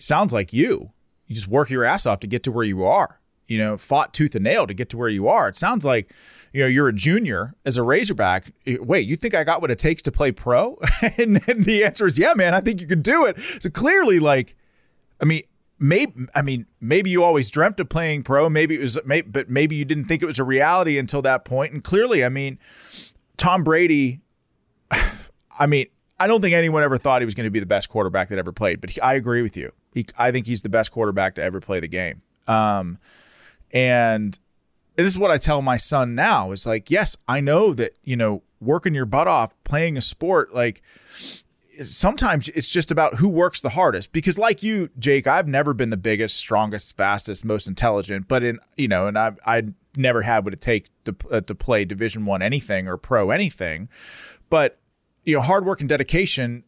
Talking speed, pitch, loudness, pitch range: 225 wpm, 135 Hz, -20 LUFS, 115-160 Hz